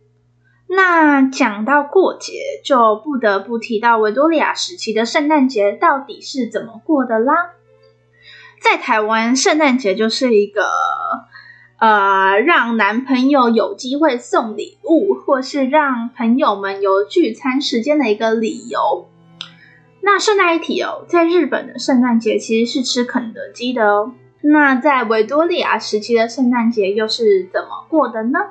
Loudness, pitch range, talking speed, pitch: -15 LUFS, 220-315 Hz, 225 characters per minute, 255 Hz